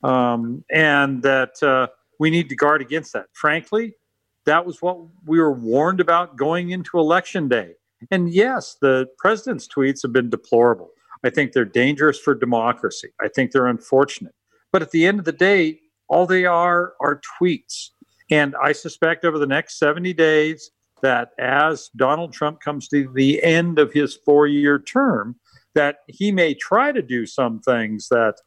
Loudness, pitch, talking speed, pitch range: -19 LUFS, 150 Hz, 170 wpm, 135-170 Hz